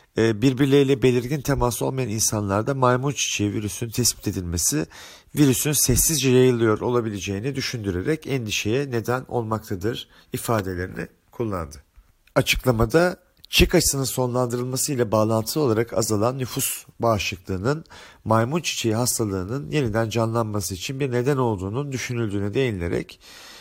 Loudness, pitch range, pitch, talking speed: -22 LUFS, 105-135 Hz, 120 Hz, 105 wpm